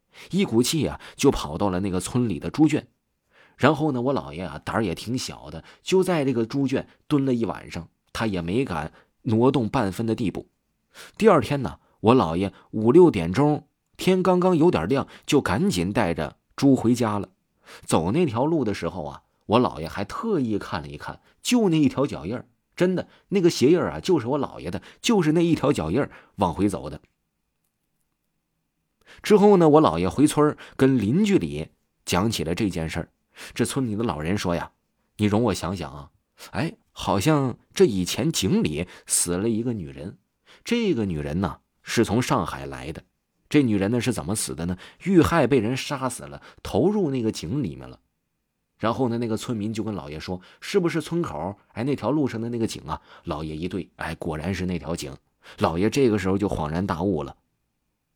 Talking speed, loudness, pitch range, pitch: 270 characters per minute, -23 LUFS, 90-145 Hz, 115 Hz